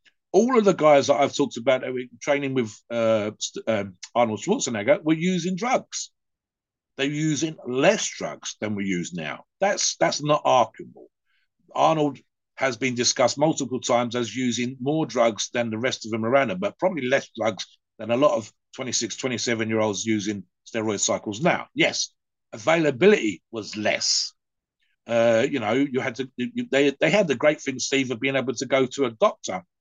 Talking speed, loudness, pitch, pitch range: 175 wpm, -23 LUFS, 130 Hz, 115-145 Hz